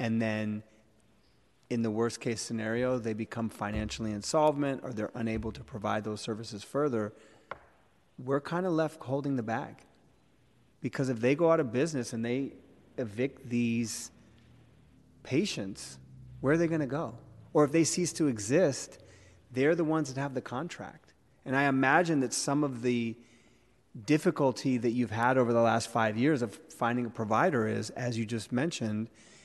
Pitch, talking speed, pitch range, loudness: 120 Hz, 165 wpm, 110-135 Hz, -31 LUFS